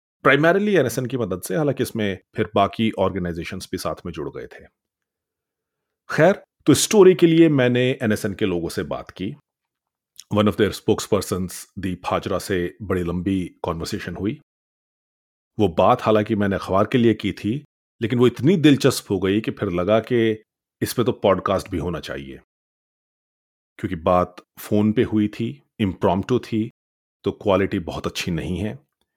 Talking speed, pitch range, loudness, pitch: 165 wpm, 95-125 Hz, -21 LUFS, 105 Hz